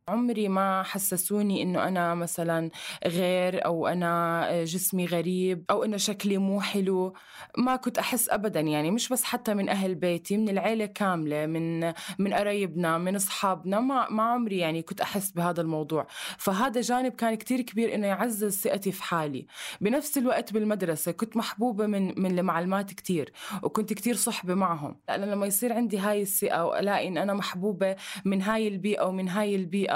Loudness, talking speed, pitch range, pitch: -28 LUFS, 165 wpm, 180-215 Hz, 195 Hz